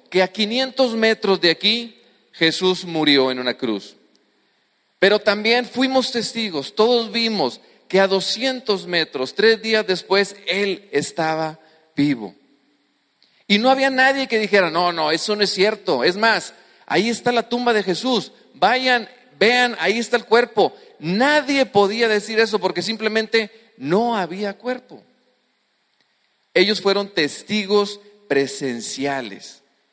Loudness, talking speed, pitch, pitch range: -19 LUFS, 130 wpm, 210 Hz, 180-235 Hz